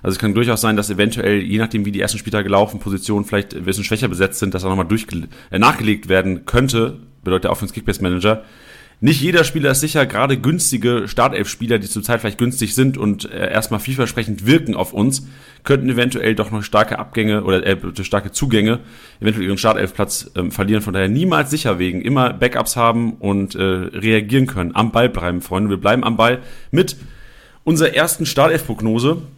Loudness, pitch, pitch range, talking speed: -17 LUFS, 110 Hz, 100-125 Hz, 190 wpm